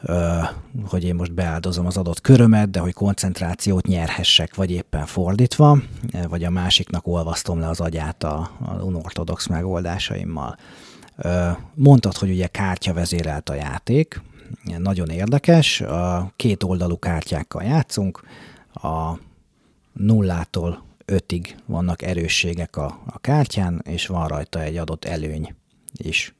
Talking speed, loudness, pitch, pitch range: 125 wpm, -21 LUFS, 90 Hz, 85-95 Hz